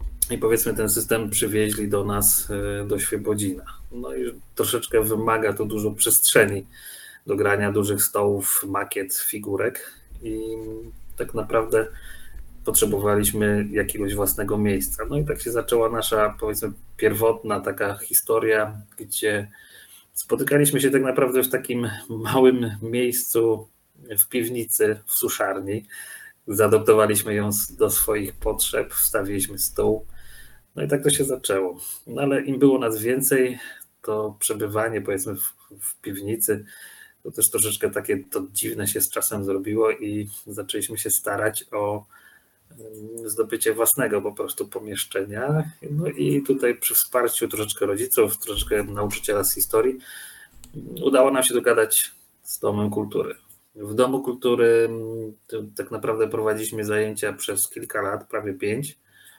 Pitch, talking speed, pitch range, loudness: 110 Hz, 130 wpm, 105-130 Hz, -22 LUFS